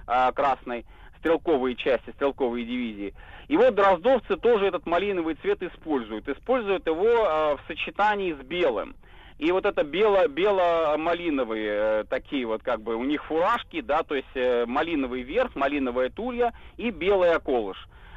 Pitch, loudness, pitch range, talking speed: 160 Hz, -25 LUFS, 125-200 Hz, 140 wpm